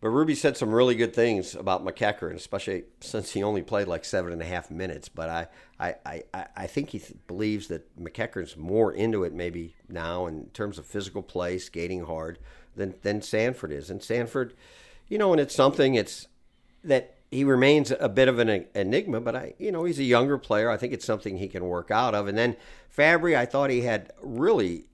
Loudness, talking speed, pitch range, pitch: -27 LUFS, 215 wpm, 85-125 Hz, 100 Hz